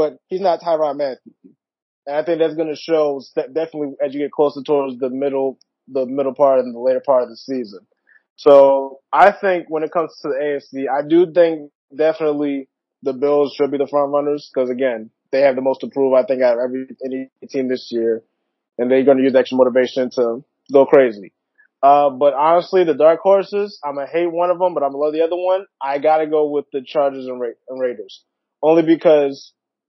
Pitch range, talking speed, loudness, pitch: 130-160 Hz, 220 wpm, -17 LUFS, 145 Hz